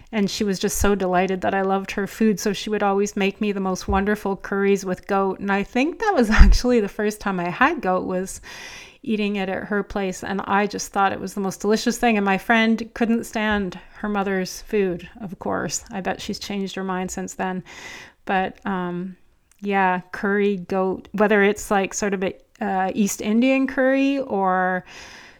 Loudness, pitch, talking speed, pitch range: -22 LUFS, 200 Hz, 200 wpm, 190-215 Hz